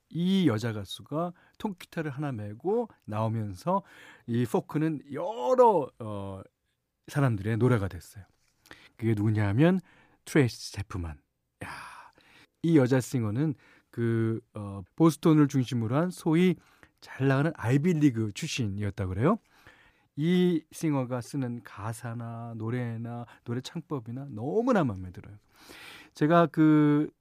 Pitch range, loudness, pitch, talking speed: 110-160 Hz, -28 LUFS, 130 Hz, 250 characters per minute